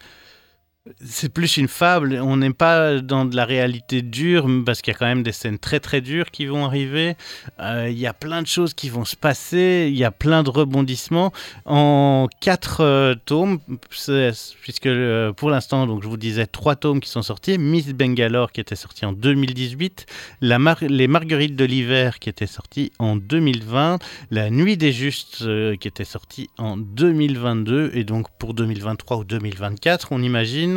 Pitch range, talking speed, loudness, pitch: 115-150 Hz, 185 wpm, -20 LUFS, 130 Hz